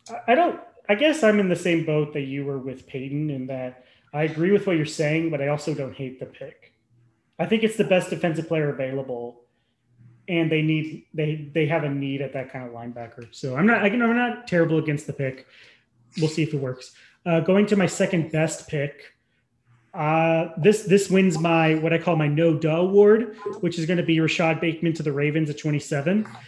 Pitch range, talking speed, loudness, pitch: 135-175 Hz, 215 wpm, -23 LUFS, 155 Hz